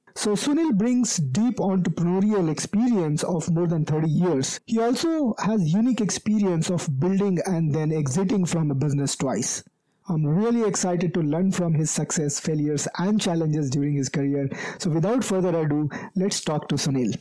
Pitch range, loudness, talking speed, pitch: 155-205 Hz, -23 LUFS, 165 wpm, 175 Hz